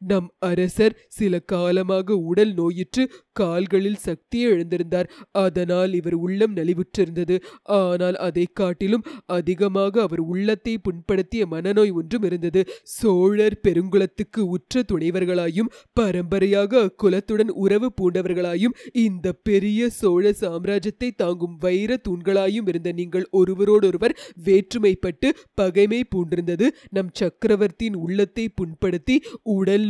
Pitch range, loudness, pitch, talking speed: 180-215 Hz, -22 LUFS, 195 Hz, 100 wpm